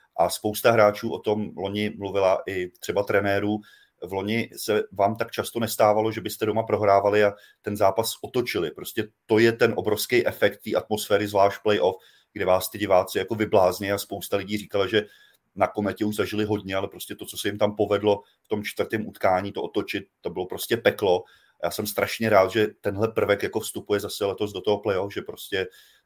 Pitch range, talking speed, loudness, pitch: 100-110 Hz, 195 wpm, -25 LUFS, 105 Hz